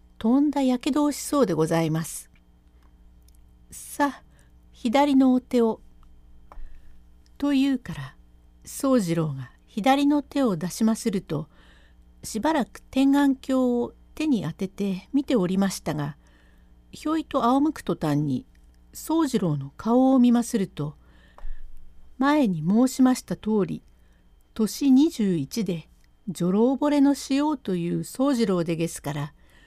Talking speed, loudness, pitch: 235 characters per minute, -24 LUFS, 185 Hz